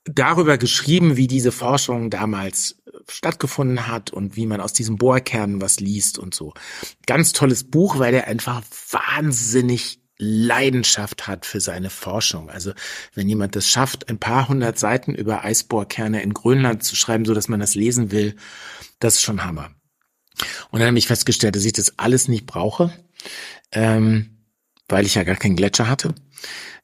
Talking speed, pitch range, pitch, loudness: 165 wpm, 105-130 Hz, 115 Hz, -19 LUFS